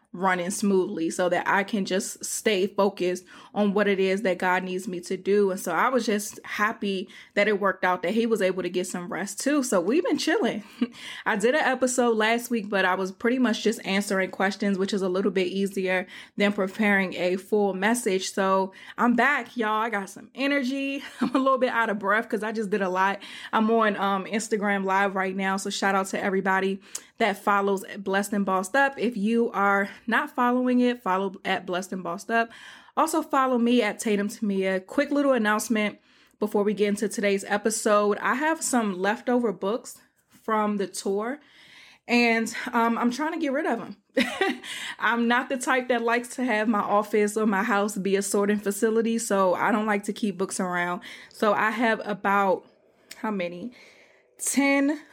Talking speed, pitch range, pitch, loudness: 200 wpm, 195-235 Hz, 210 Hz, -25 LUFS